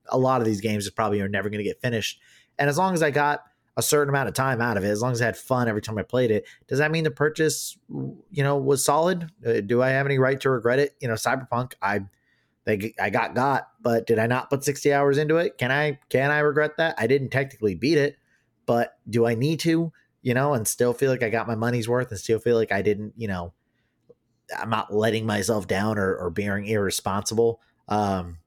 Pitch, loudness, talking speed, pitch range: 120 Hz, -24 LUFS, 245 wpm, 110-140 Hz